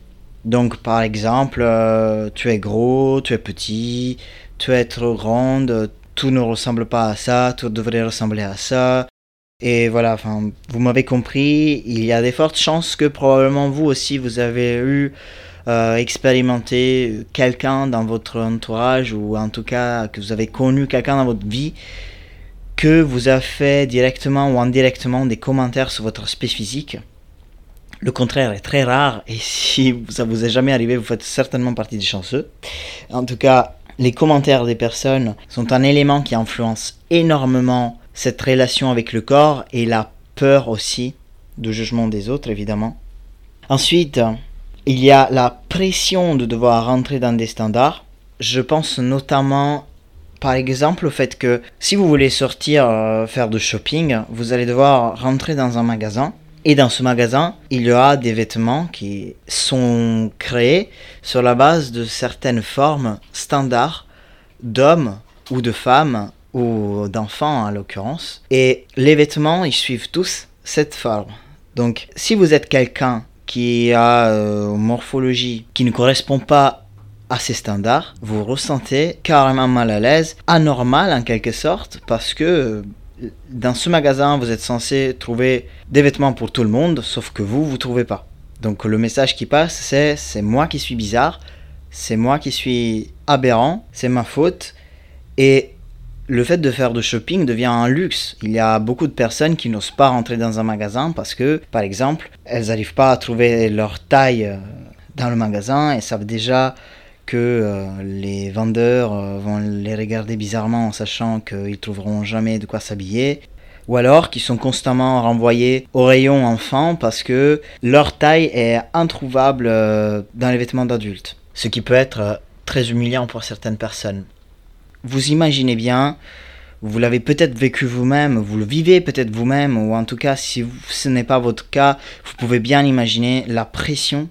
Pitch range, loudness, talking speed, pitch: 110-135 Hz, -17 LUFS, 165 wpm, 120 Hz